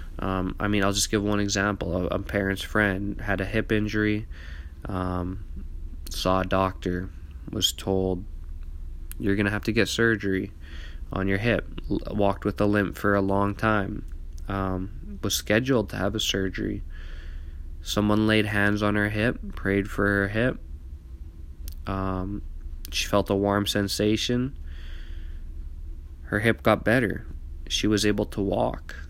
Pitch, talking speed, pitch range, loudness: 95 Hz, 150 wpm, 75-105 Hz, -26 LUFS